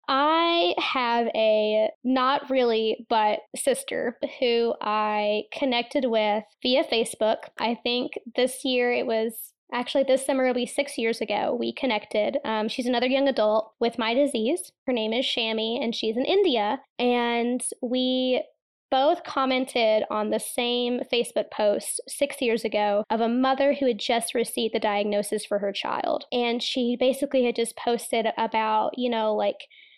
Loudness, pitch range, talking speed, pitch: -25 LUFS, 220-265 Hz, 160 wpm, 240 Hz